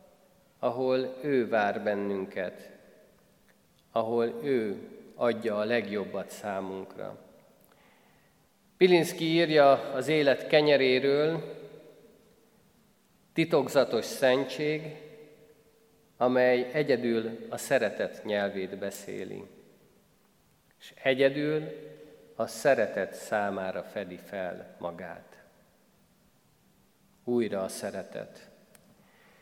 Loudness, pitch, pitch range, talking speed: -28 LUFS, 130 Hz, 115-155 Hz, 70 wpm